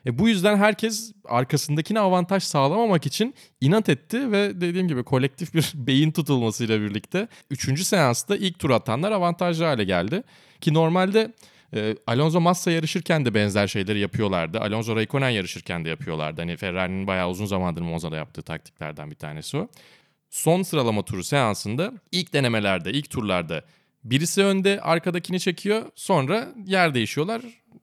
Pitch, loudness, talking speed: 145 Hz, -23 LUFS, 145 wpm